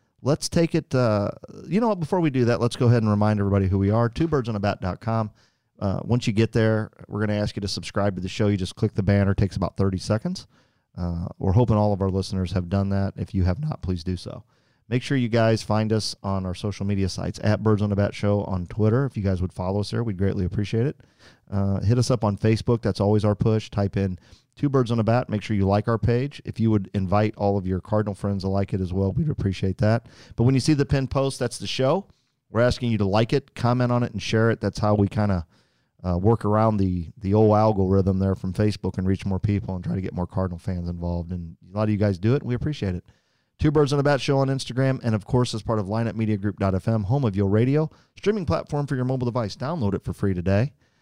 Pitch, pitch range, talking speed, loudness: 105 Hz, 100-120 Hz, 260 wpm, -24 LUFS